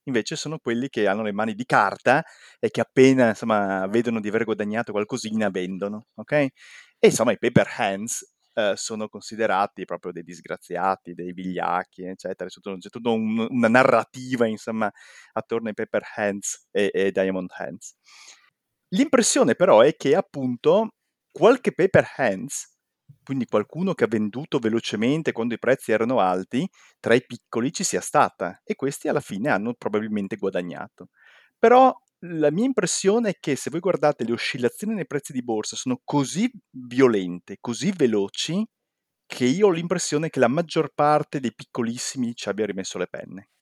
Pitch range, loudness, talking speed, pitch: 105-155 Hz, -23 LUFS, 160 wpm, 120 Hz